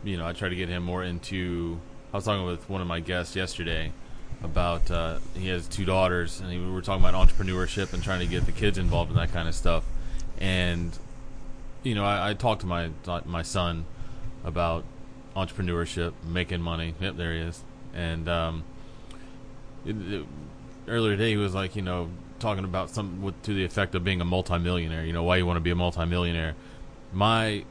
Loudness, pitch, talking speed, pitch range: -29 LUFS, 90 Hz, 195 wpm, 85-105 Hz